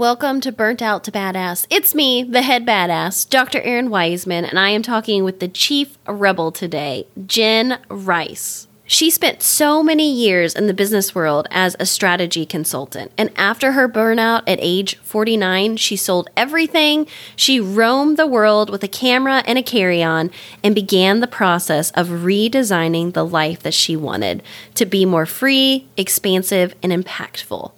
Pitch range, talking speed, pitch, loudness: 180-245 Hz, 165 wpm, 205 Hz, -16 LUFS